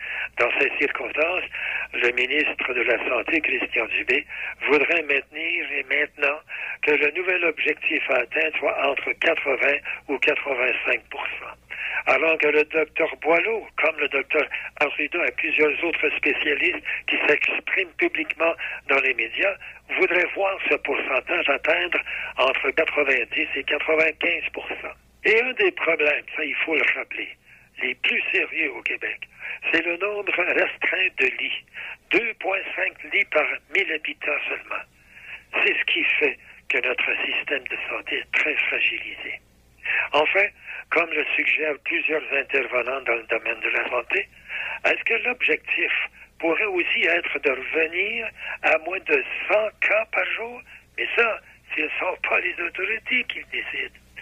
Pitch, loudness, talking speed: 170 Hz, -22 LUFS, 145 wpm